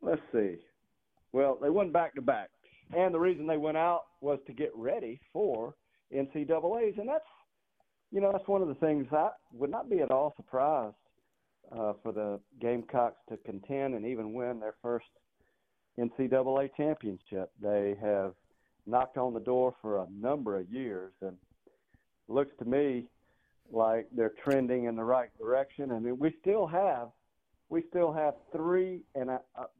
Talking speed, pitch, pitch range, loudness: 170 wpm, 130 Hz, 115-155 Hz, -32 LUFS